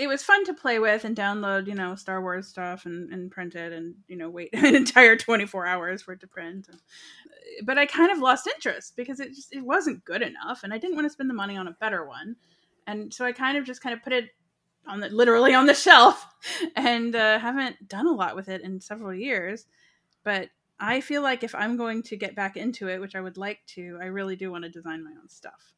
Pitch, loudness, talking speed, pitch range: 210 Hz, -23 LUFS, 250 wpm, 185-260 Hz